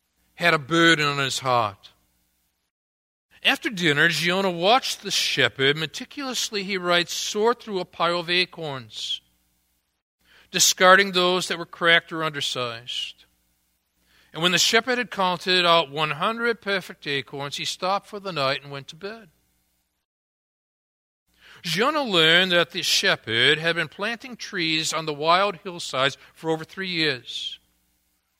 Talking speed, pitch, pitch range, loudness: 135 wpm, 160 Hz, 125-185 Hz, -22 LUFS